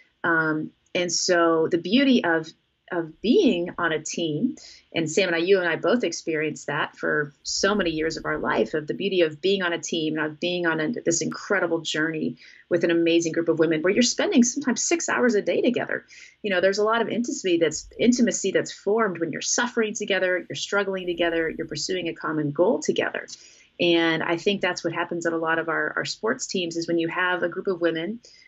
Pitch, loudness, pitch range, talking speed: 175 Hz, -24 LUFS, 165-195 Hz, 220 wpm